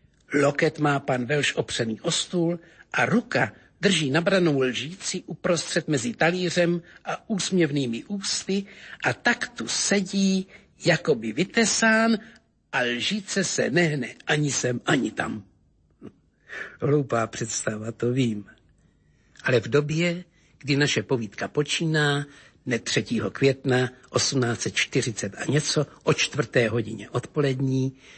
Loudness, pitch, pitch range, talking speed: -24 LUFS, 145 Hz, 125-175 Hz, 115 wpm